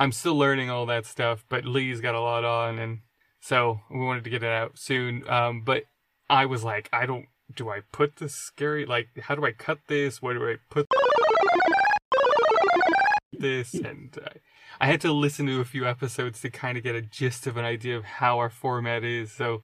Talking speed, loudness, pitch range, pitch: 210 wpm, -26 LUFS, 120-145 Hz, 130 Hz